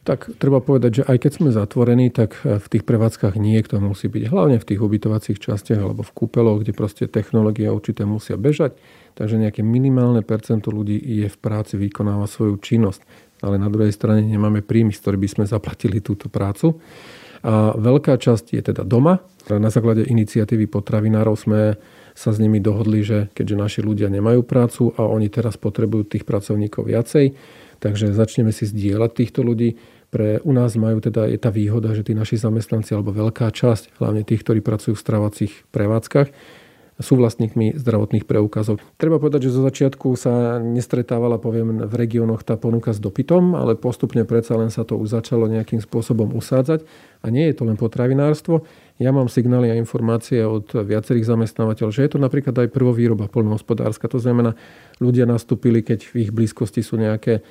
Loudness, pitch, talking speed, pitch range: -19 LUFS, 115 Hz, 175 wpm, 110-120 Hz